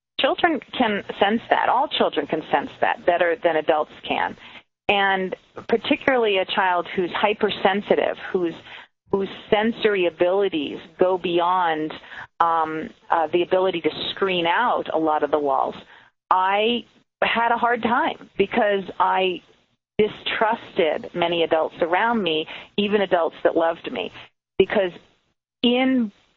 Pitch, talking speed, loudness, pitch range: 190 Hz, 125 wpm, -22 LUFS, 170-230 Hz